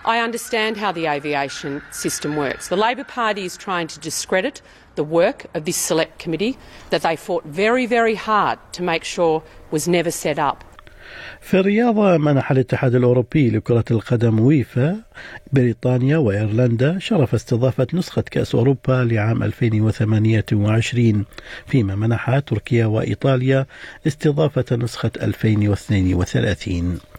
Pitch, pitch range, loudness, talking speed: 130 Hz, 115-170 Hz, -19 LUFS, 125 wpm